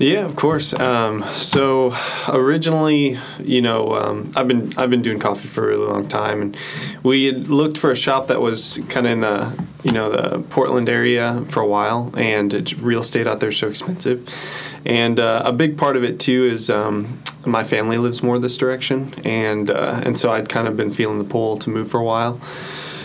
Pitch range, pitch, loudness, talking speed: 115-135 Hz, 125 Hz, -19 LUFS, 215 wpm